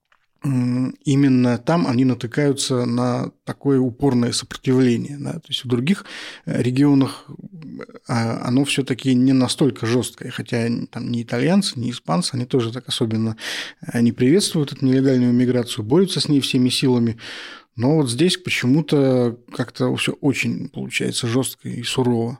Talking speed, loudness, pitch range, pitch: 135 wpm, -20 LUFS, 120-140 Hz, 130 Hz